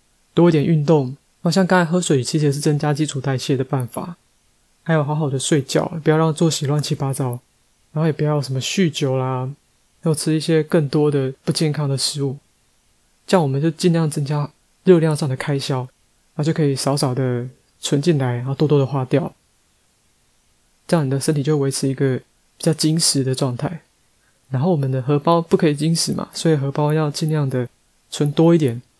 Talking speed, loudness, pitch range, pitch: 290 characters per minute, -19 LUFS, 135-160 Hz, 150 Hz